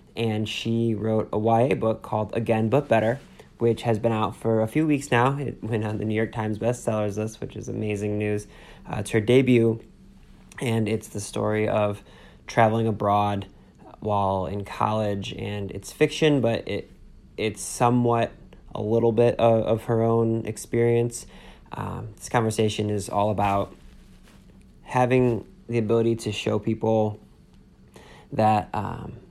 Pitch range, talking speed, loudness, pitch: 105-115 Hz, 155 wpm, -24 LUFS, 110 Hz